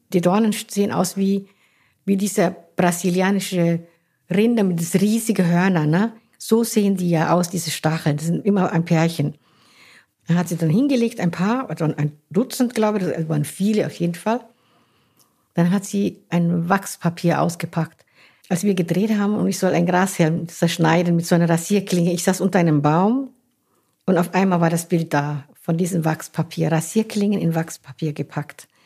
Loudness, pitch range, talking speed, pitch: -20 LUFS, 165-200 Hz, 175 wpm, 175 Hz